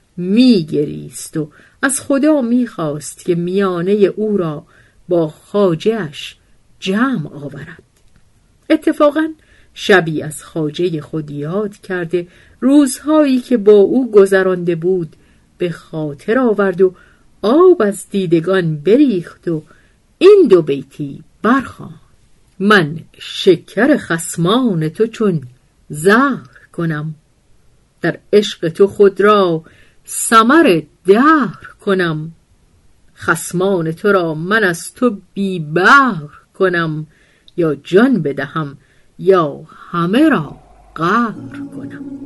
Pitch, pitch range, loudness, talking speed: 185 Hz, 160-220 Hz, -14 LUFS, 100 wpm